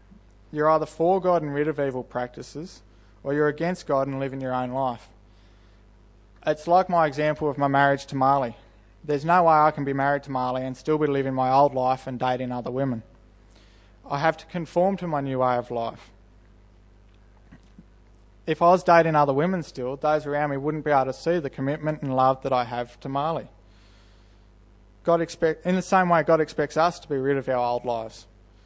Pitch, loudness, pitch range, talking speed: 135 Hz, -24 LUFS, 110-155 Hz, 205 wpm